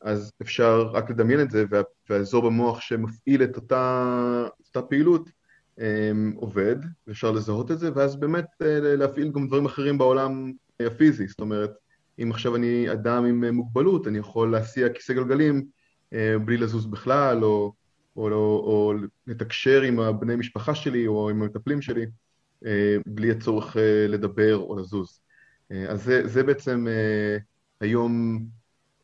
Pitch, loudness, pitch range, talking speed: 115 Hz, -24 LUFS, 105-130 Hz, 135 wpm